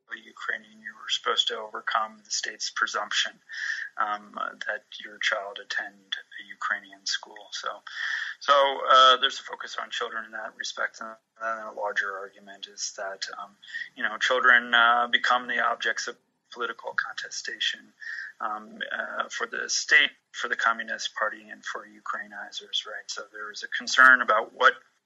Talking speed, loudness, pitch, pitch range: 160 wpm, -25 LUFS, 120 Hz, 110-140 Hz